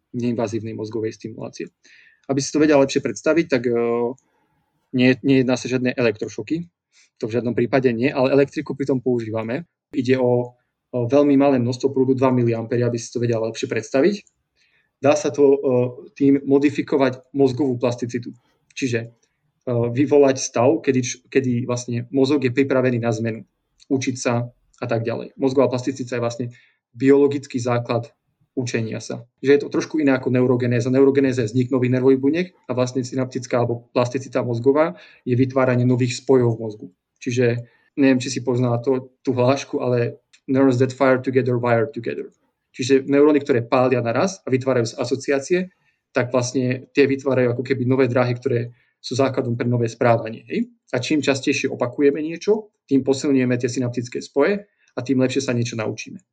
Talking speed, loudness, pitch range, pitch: 160 wpm, -20 LUFS, 120-140 Hz, 130 Hz